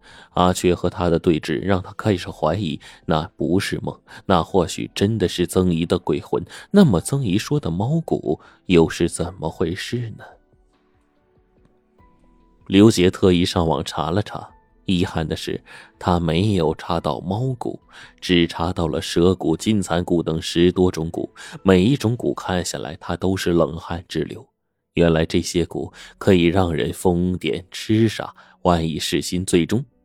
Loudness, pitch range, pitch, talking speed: -20 LUFS, 85-95 Hz, 90 Hz, 220 characters per minute